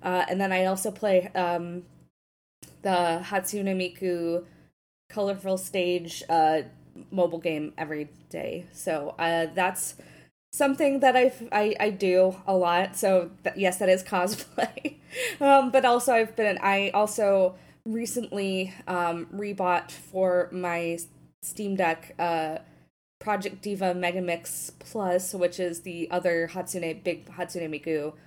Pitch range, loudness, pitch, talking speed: 170-200 Hz, -27 LUFS, 185 Hz, 130 wpm